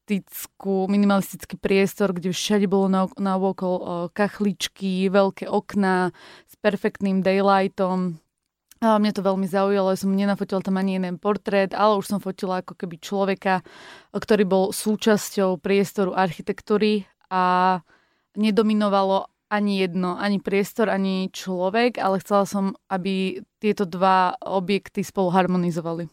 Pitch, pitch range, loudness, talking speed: 195 Hz, 190-205 Hz, -23 LUFS, 125 wpm